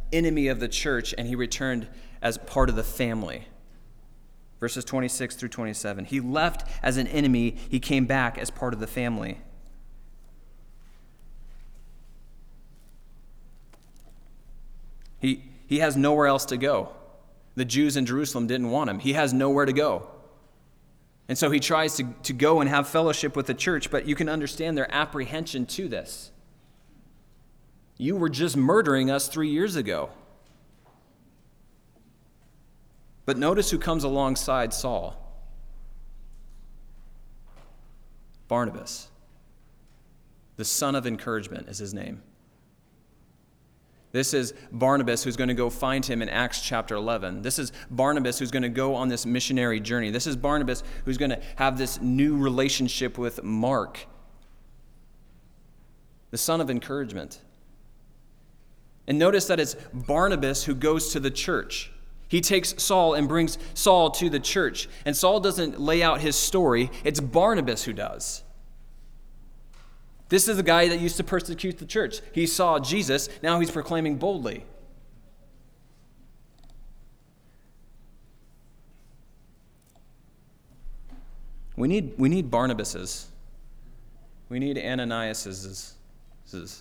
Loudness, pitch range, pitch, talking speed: -25 LUFS, 120-155 Hz, 135 Hz, 130 wpm